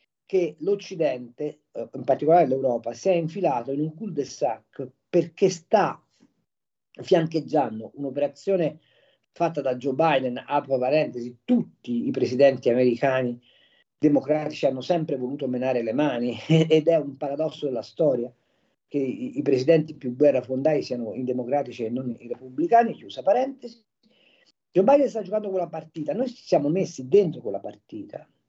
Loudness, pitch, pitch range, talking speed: -24 LUFS, 150 Hz, 130-180 Hz, 145 wpm